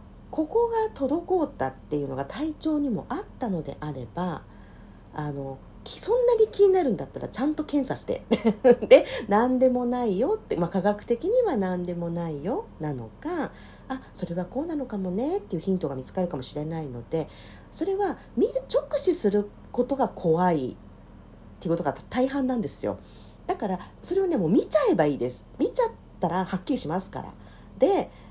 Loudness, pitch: -26 LUFS, 210 Hz